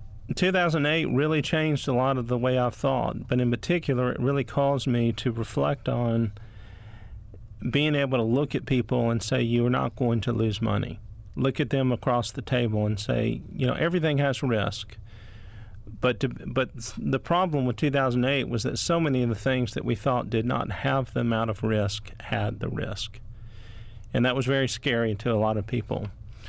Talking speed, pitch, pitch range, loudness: 195 wpm, 120 Hz, 110-135 Hz, -26 LUFS